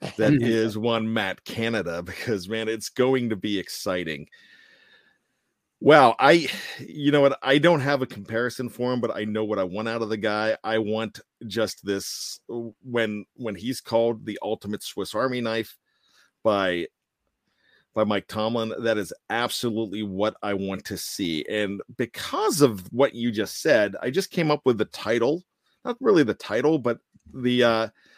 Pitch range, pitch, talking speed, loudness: 110-130 Hz, 115 Hz, 170 wpm, -24 LUFS